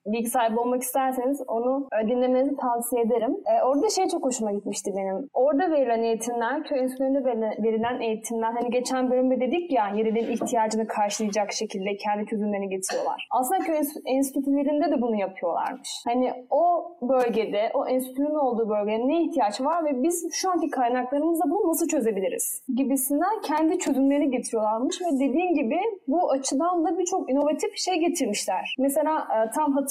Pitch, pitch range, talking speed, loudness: 260 Hz, 230-310 Hz, 145 wpm, -25 LUFS